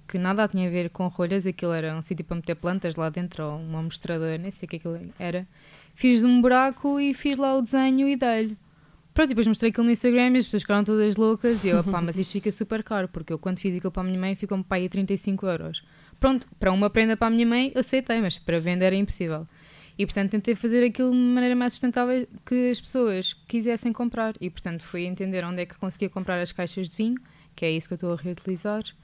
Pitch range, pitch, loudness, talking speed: 175-235 Hz, 195 Hz, -25 LUFS, 245 wpm